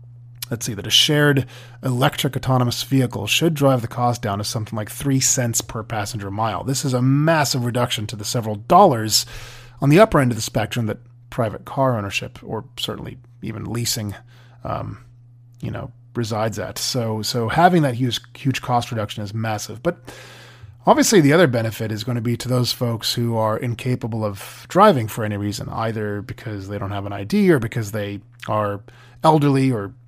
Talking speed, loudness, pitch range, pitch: 185 wpm, -20 LUFS, 110-130 Hz, 120 Hz